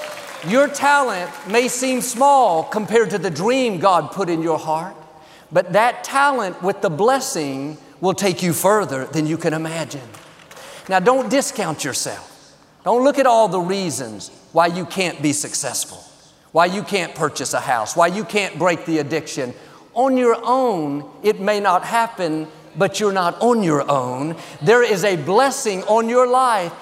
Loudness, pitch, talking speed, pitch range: -18 LUFS, 185 Hz, 170 wpm, 160-230 Hz